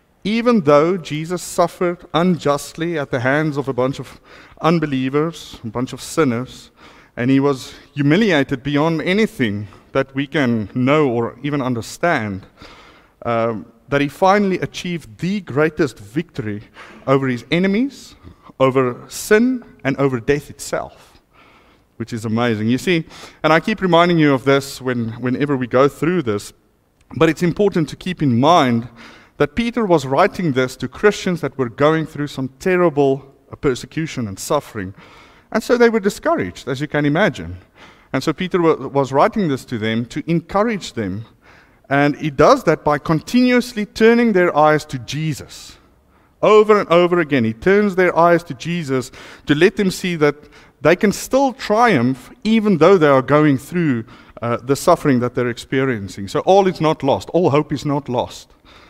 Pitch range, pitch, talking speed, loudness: 125-175 Hz, 145 Hz, 165 wpm, -17 LUFS